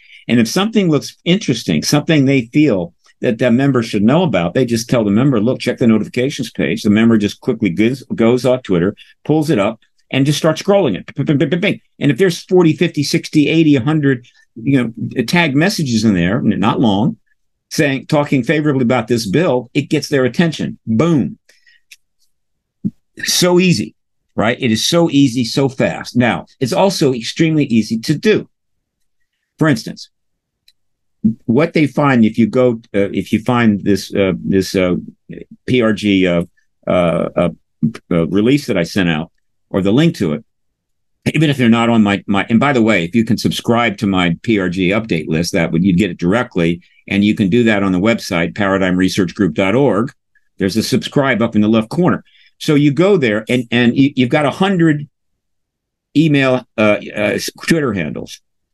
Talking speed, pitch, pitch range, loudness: 175 wpm, 125 Hz, 105-155 Hz, -15 LUFS